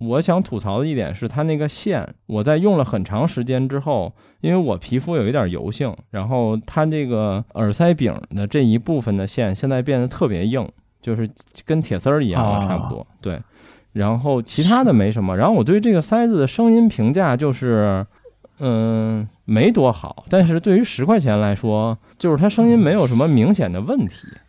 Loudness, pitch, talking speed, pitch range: -18 LUFS, 125 Hz, 285 characters per minute, 105-160 Hz